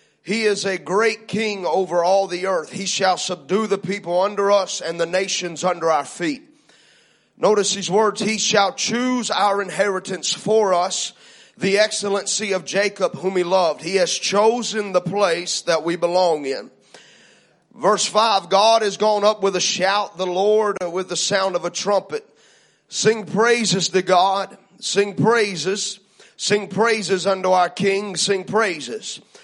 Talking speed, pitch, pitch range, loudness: 160 wpm, 195 Hz, 185-210 Hz, -19 LUFS